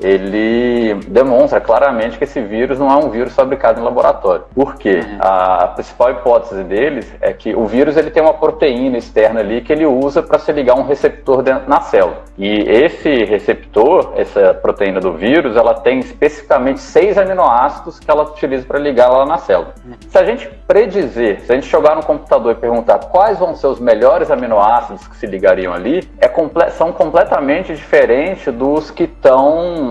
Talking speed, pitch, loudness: 180 wpm, 155 Hz, -13 LUFS